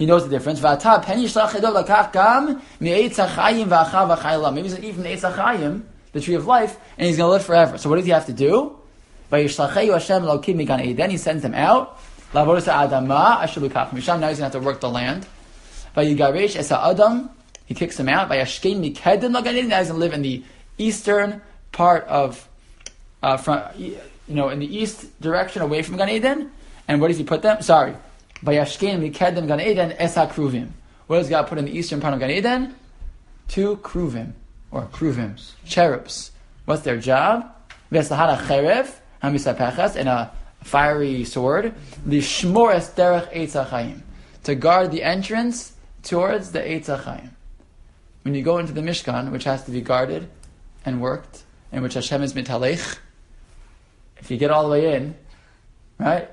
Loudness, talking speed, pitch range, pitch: -20 LUFS, 135 wpm, 135-190 Hz, 155 Hz